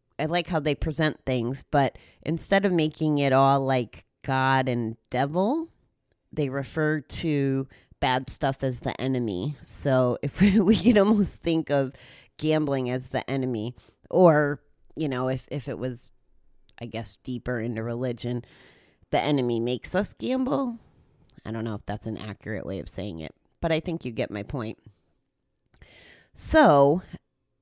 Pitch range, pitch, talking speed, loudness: 120-155 Hz, 135 Hz, 155 wpm, -26 LUFS